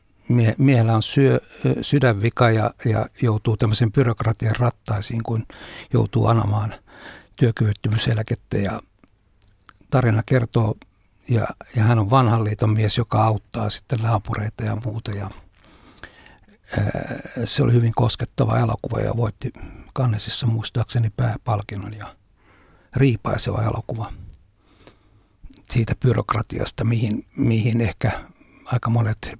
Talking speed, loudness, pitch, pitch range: 105 wpm, -21 LUFS, 115 Hz, 105-120 Hz